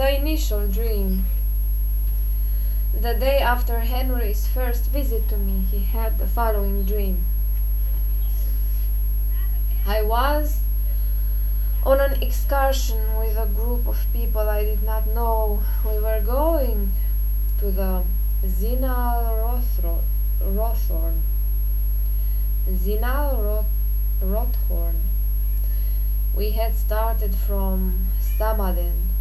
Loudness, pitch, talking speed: -24 LUFS, 190 Hz, 90 wpm